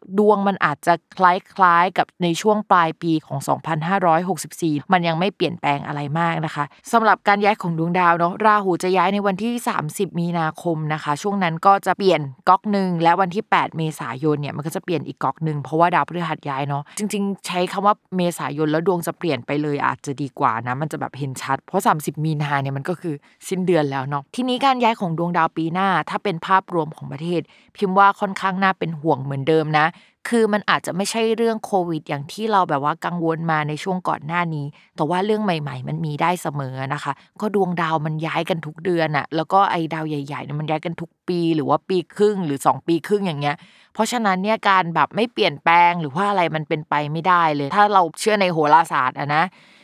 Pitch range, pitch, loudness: 155-195 Hz, 170 Hz, -20 LUFS